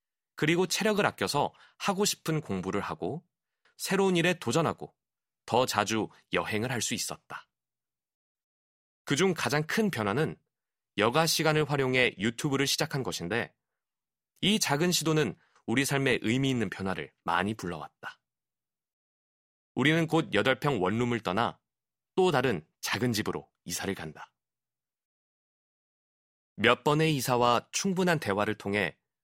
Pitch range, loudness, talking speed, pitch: 100-160 Hz, -28 LUFS, 255 characters per minute, 125 Hz